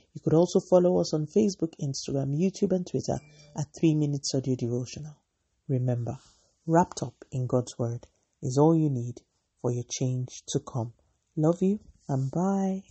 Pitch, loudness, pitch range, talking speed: 150 Hz, -28 LUFS, 125-165 Hz, 165 wpm